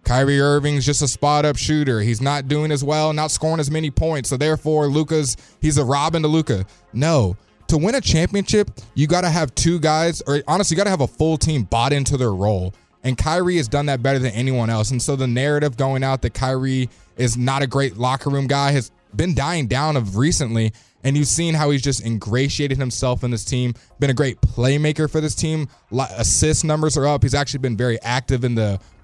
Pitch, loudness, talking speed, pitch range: 140 Hz, -19 LUFS, 225 wpm, 125-150 Hz